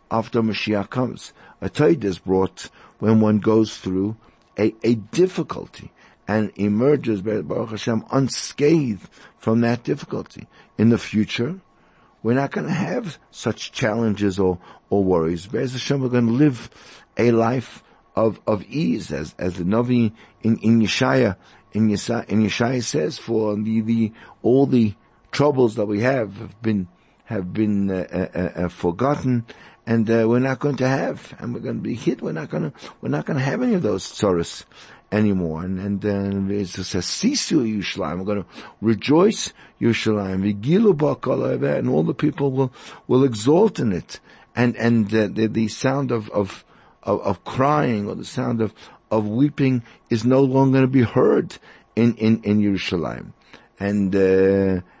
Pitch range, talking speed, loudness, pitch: 100-125 Hz, 165 wpm, -21 LUFS, 110 Hz